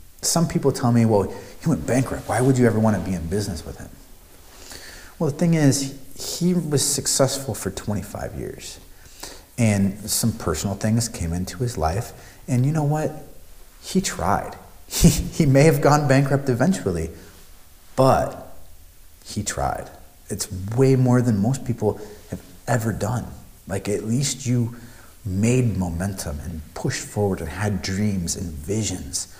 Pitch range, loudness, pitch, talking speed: 90-130 Hz, -22 LUFS, 105 Hz, 155 wpm